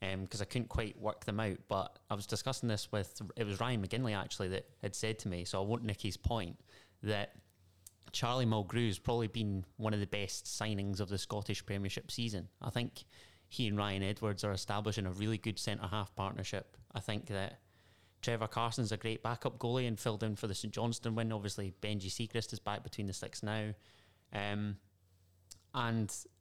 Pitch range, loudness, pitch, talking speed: 95-115 Hz, -39 LUFS, 105 Hz, 200 wpm